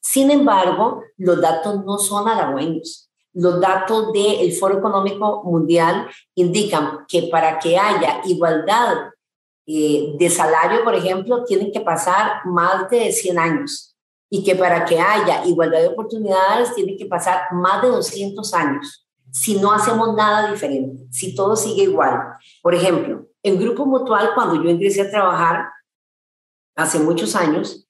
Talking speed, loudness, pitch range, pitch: 145 wpm, -17 LUFS, 165-210 Hz, 185 Hz